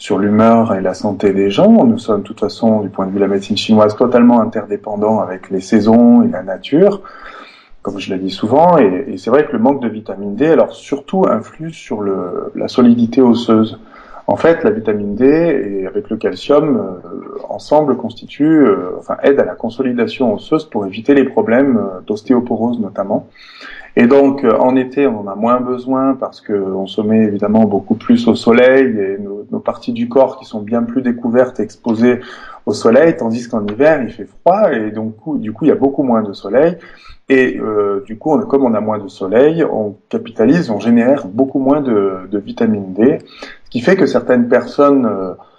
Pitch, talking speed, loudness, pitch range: 120 Hz, 205 wpm, -13 LUFS, 105-140 Hz